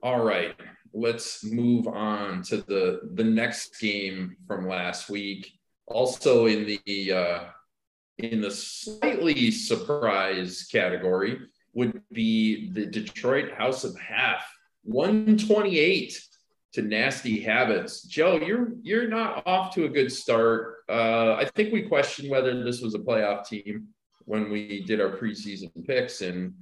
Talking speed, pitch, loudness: 140 wpm, 115 Hz, -26 LUFS